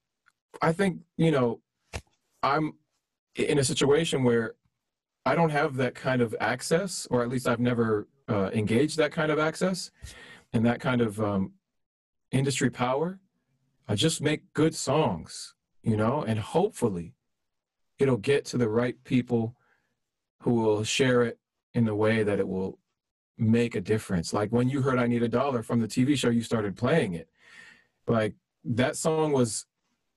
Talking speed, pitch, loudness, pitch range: 165 wpm, 125 Hz, -27 LUFS, 110-145 Hz